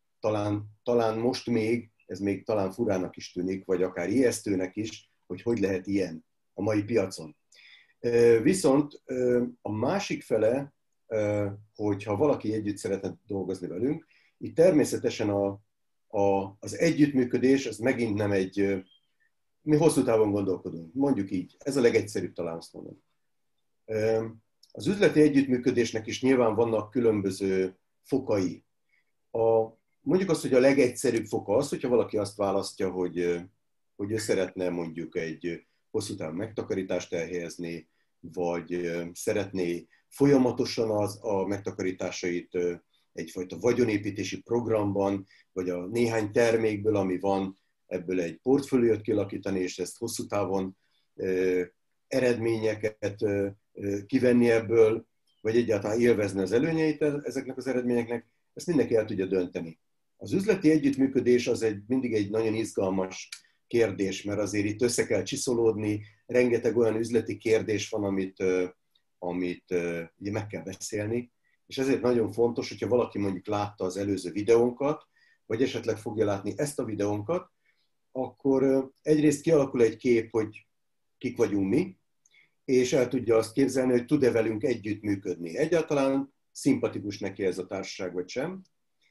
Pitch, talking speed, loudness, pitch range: 105 Hz, 130 wpm, -28 LUFS, 95-120 Hz